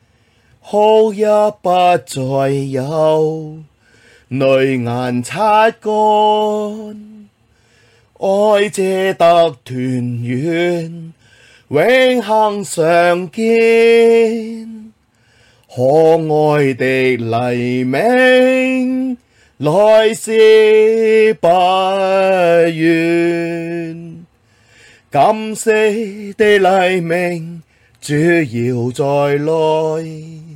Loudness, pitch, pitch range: -13 LUFS, 170 Hz, 135-215 Hz